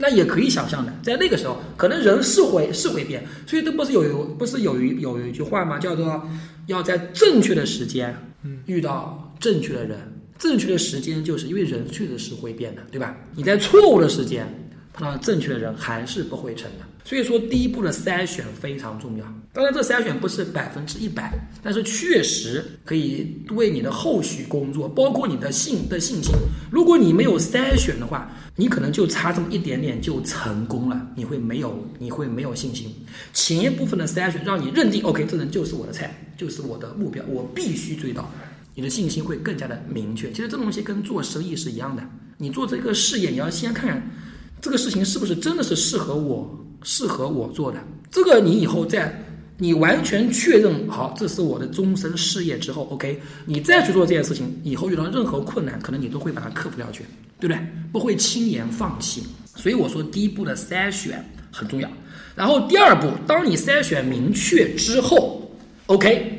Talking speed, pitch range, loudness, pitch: 305 characters per minute, 145-220 Hz, -21 LUFS, 180 Hz